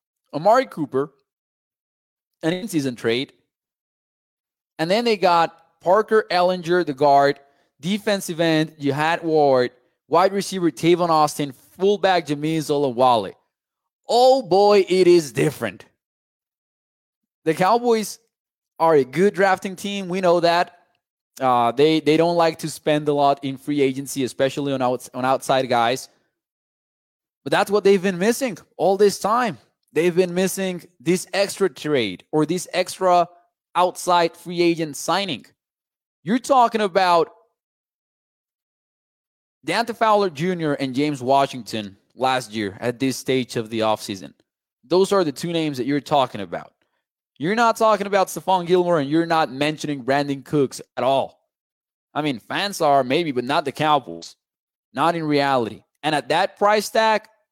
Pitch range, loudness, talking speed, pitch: 135-185 Hz, -20 LUFS, 140 wpm, 160 Hz